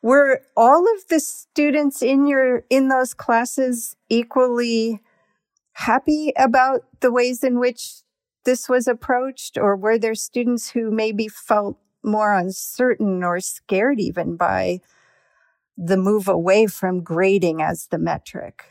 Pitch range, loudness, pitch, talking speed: 210-260 Hz, -19 LUFS, 240 Hz, 130 wpm